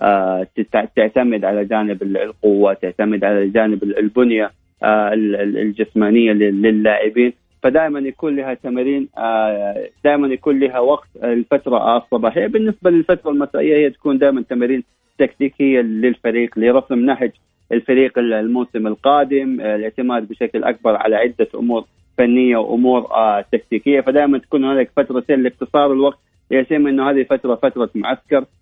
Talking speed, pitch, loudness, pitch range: 115 wpm, 120 Hz, -16 LUFS, 110-140 Hz